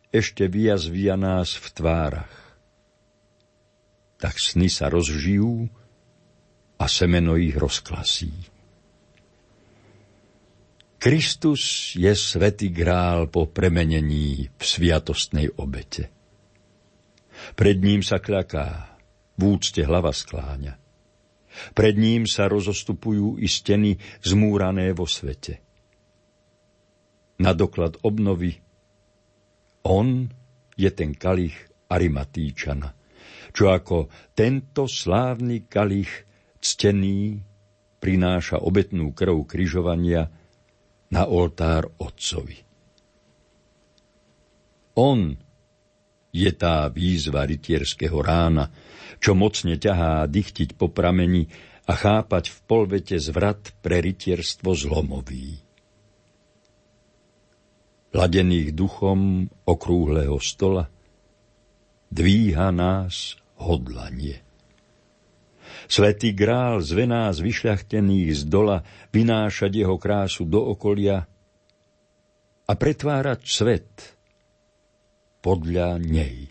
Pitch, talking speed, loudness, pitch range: 95 Hz, 80 wpm, -22 LUFS, 85-100 Hz